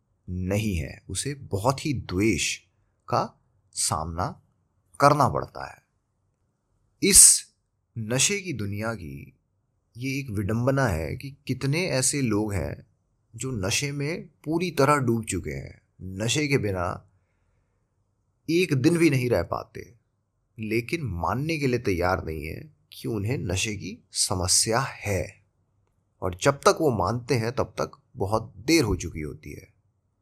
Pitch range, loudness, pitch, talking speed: 95-135 Hz, -24 LUFS, 110 Hz, 135 wpm